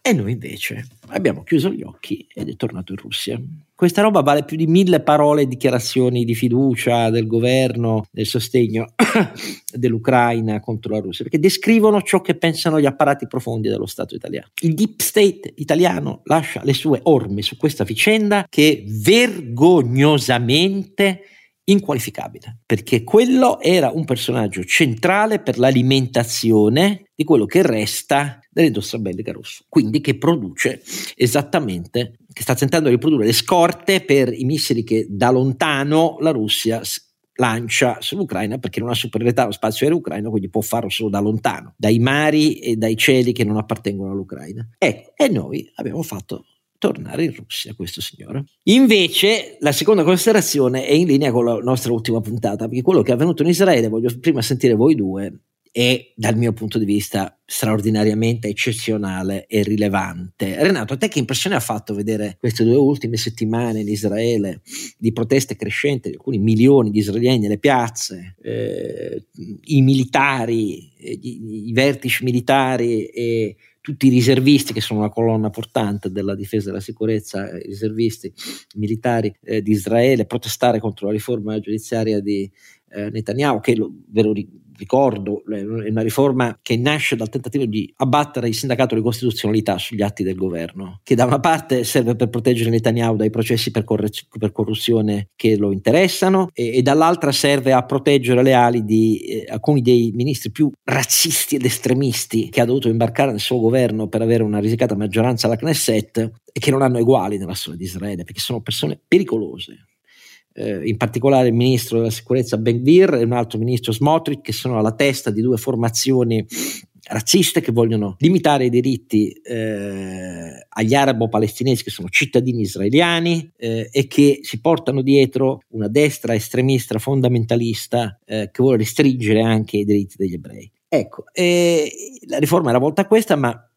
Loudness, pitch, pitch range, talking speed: -18 LUFS, 120 Hz, 110-140 Hz, 160 wpm